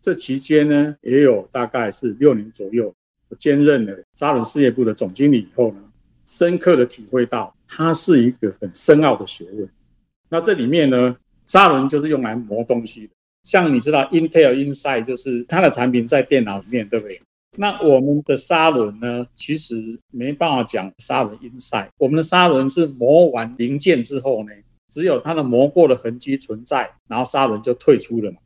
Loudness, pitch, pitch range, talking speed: -17 LUFS, 125 Hz, 115-145 Hz, 300 characters per minute